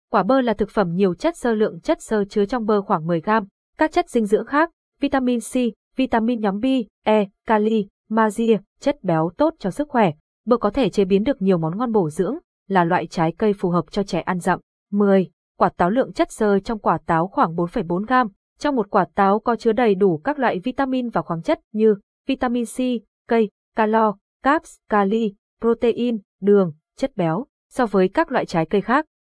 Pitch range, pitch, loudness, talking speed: 195-250 Hz, 220 Hz, -21 LUFS, 205 wpm